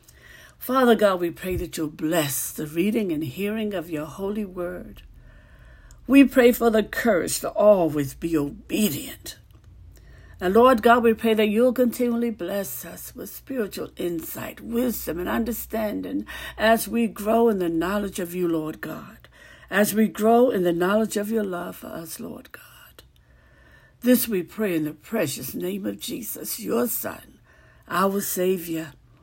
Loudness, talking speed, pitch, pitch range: -23 LUFS, 155 wpm, 205 Hz, 170-230 Hz